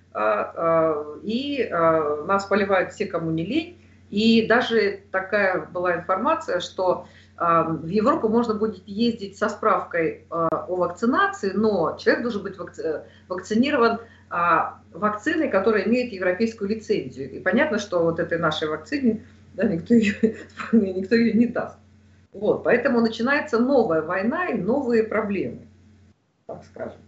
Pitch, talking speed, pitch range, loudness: 210 Hz, 125 wpm, 175-230 Hz, -23 LUFS